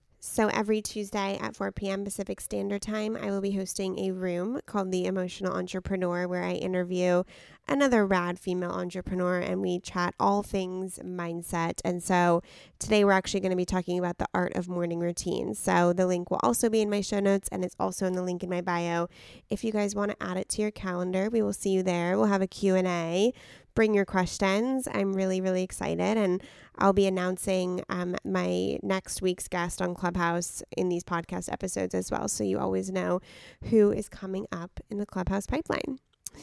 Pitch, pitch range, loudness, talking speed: 185 Hz, 175-200 Hz, -29 LUFS, 200 wpm